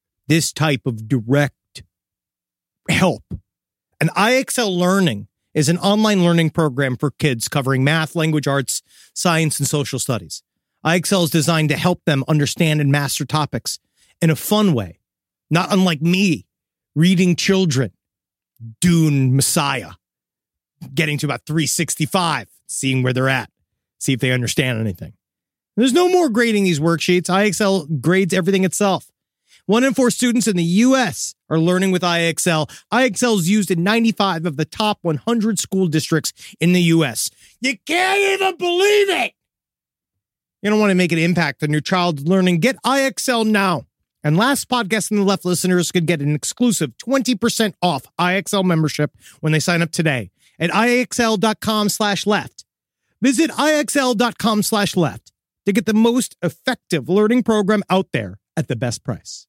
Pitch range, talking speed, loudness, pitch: 145-210 Hz, 150 wpm, -18 LUFS, 175 Hz